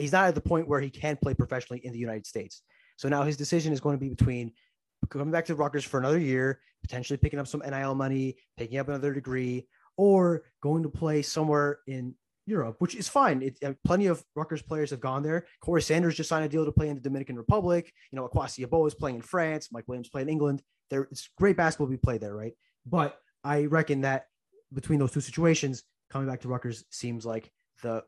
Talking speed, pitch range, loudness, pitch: 230 wpm, 130-160 Hz, -29 LUFS, 140 Hz